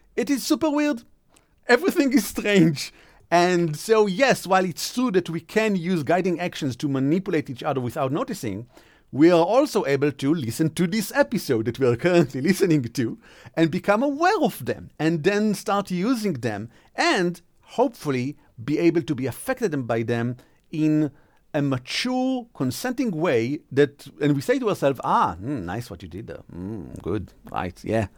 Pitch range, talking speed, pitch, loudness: 140-210 Hz, 175 wpm, 170 Hz, -23 LUFS